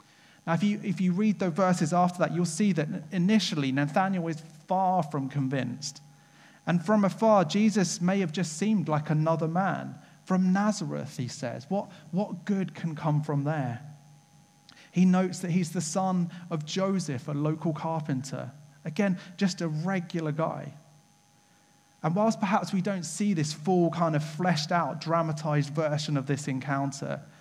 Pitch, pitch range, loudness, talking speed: 165 Hz, 155-190 Hz, -28 LUFS, 160 wpm